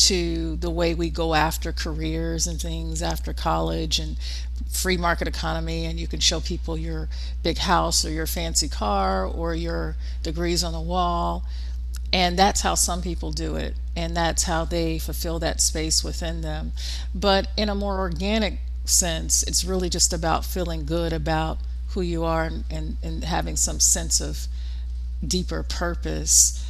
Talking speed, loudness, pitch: 165 wpm, -24 LUFS, 80 Hz